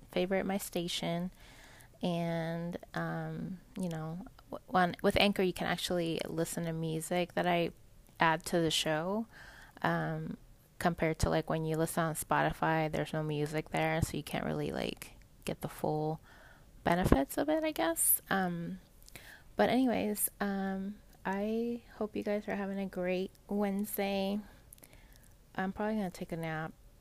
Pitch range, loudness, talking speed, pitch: 160-195 Hz, -34 LUFS, 150 wpm, 175 Hz